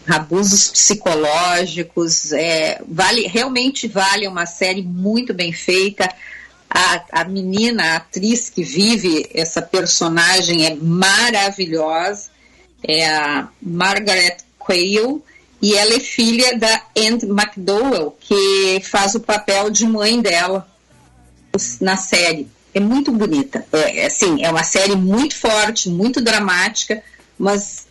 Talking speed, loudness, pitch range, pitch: 120 wpm, -15 LUFS, 175-220 Hz, 195 Hz